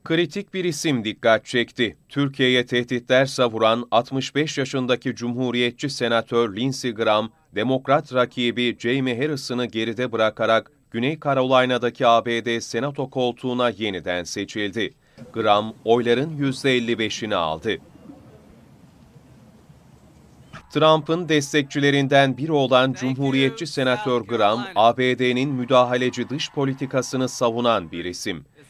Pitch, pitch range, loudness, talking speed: 125 Hz, 115-135 Hz, -21 LUFS, 95 wpm